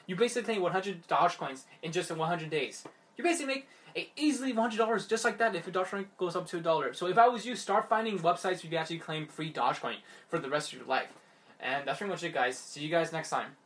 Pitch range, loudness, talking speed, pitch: 160-225 Hz, -32 LUFS, 285 wpm, 180 Hz